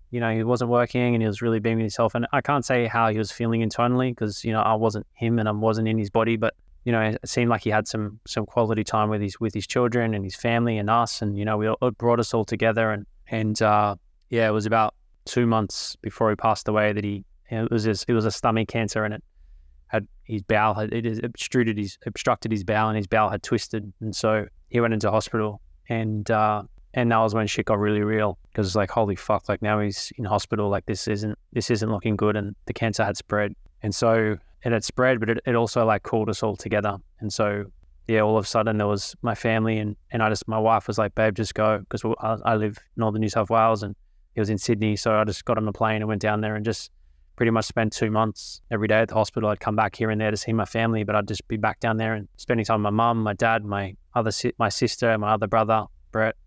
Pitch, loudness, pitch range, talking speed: 110 Hz, -24 LUFS, 105-115 Hz, 265 wpm